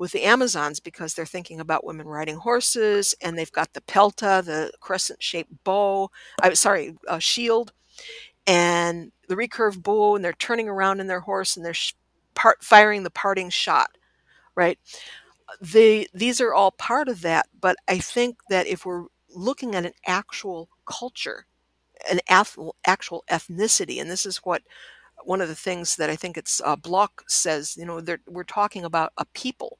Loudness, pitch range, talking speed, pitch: -22 LUFS, 170-215 Hz, 175 wpm, 190 Hz